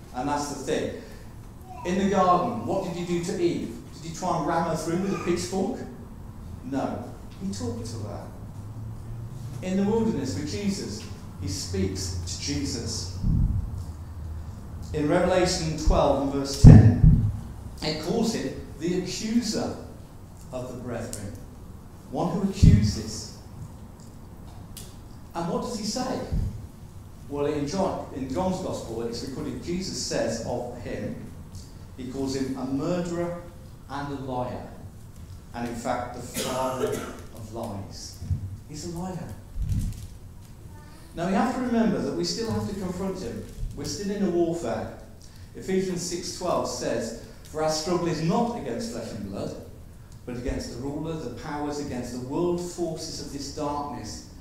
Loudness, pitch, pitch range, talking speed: -27 LUFS, 125 Hz, 105-170 Hz, 145 wpm